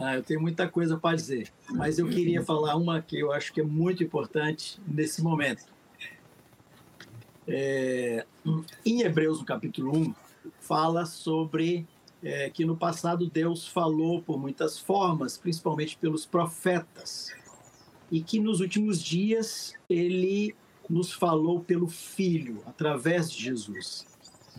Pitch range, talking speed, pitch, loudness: 155-175 Hz, 130 wpm, 165 Hz, -29 LUFS